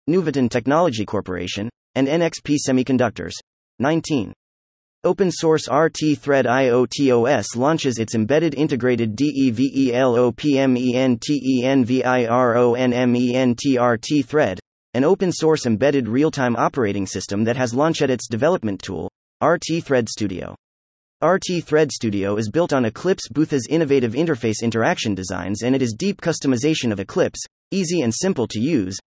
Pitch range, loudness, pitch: 115-150 Hz, -20 LUFS, 130 Hz